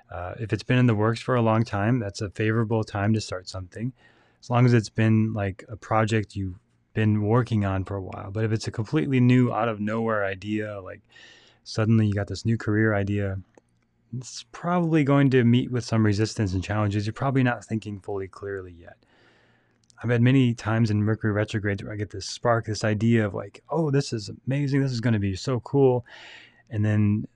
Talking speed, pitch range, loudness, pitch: 215 wpm, 105-120 Hz, -25 LUFS, 110 Hz